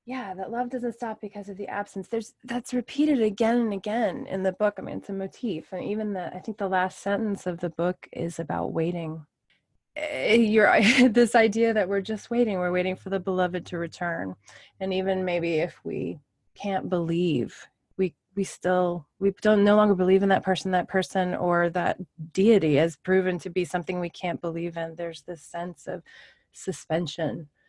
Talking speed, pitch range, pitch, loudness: 190 wpm, 175-215 Hz, 190 Hz, -26 LUFS